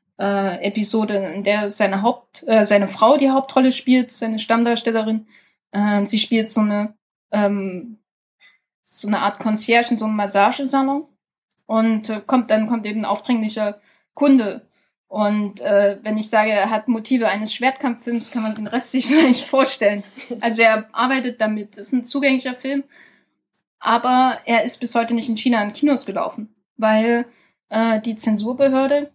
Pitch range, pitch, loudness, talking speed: 210-250 Hz, 225 Hz, -19 LUFS, 160 wpm